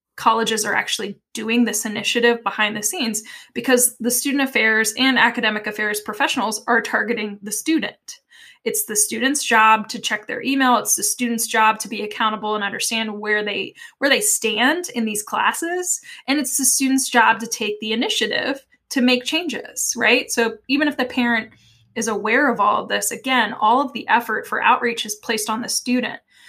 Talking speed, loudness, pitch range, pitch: 185 wpm, -19 LUFS, 215-260 Hz, 230 Hz